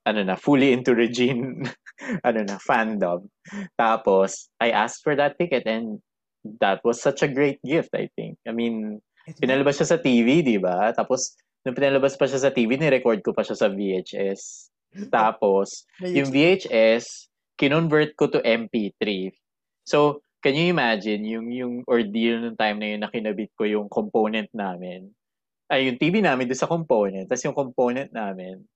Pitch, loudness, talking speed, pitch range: 120 Hz, -23 LUFS, 165 wpm, 105-140 Hz